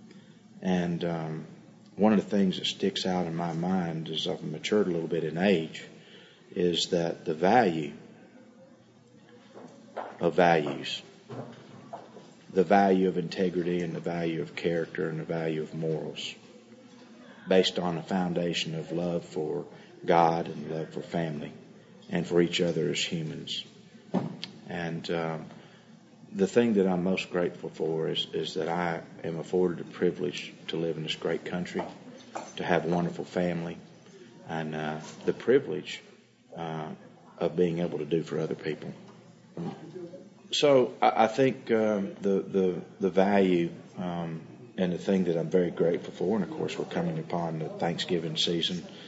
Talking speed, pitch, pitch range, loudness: 155 wpm, 90 Hz, 80-100 Hz, -29 LUFS